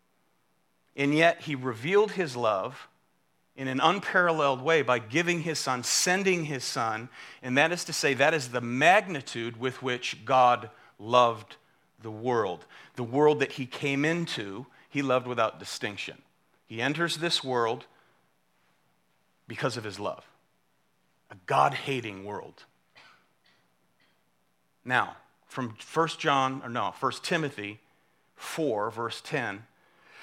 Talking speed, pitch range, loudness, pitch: 130 wpm, 120-160 Hz, -27 LUFS, 135 Hz